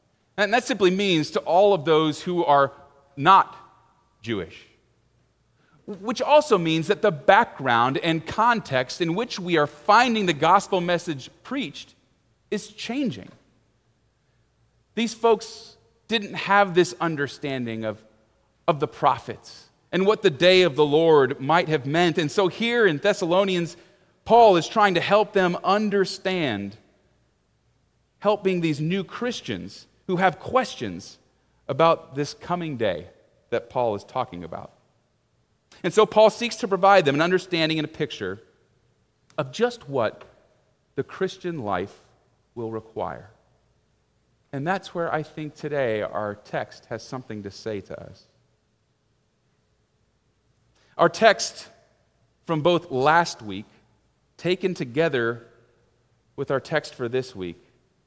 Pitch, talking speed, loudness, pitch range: 170 Hz, 130 wpm, -22 LUFS, 135-195 Hz